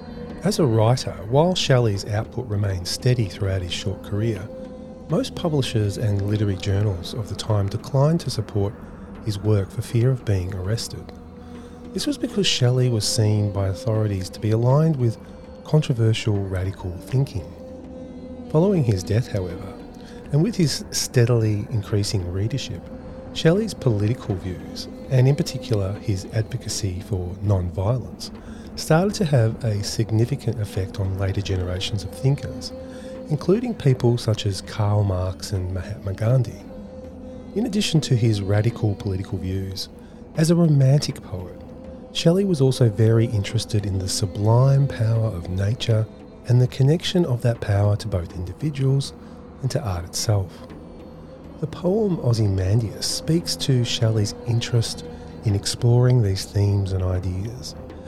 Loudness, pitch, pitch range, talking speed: -22 LUFS, 110 Hz, 100-130 Hz, 135 wpm